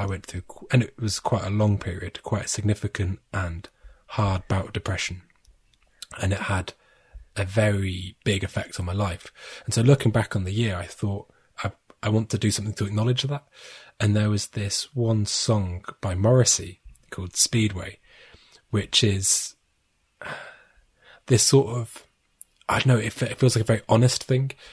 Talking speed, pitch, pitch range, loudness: 175 wpm, 105 Hz, 95-115 Hz, -24 LUFS